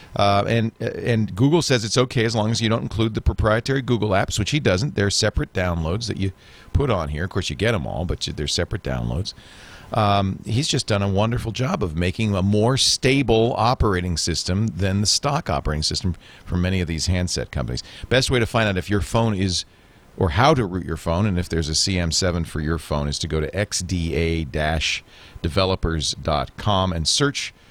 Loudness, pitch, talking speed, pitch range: -21 LUFS, 100 Hz, 200 wpm, 85-115 Hz